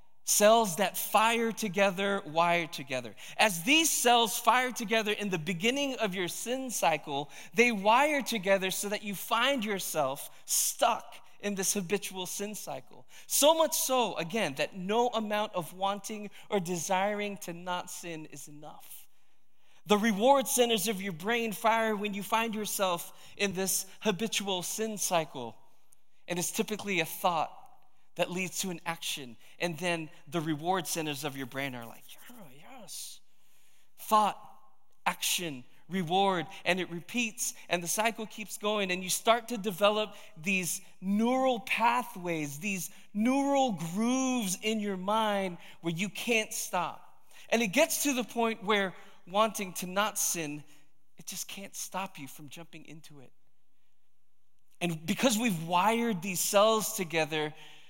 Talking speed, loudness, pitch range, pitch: 145 wpm, -30 LUFS, 175-220 Hz, 200 Hz